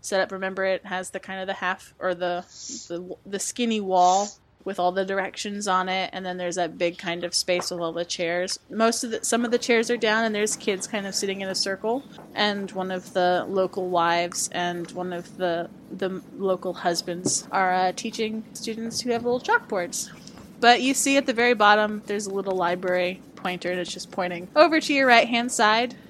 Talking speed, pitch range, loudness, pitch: 220 wpm, 180-225 Hz, -24 LUFS, 190 Hz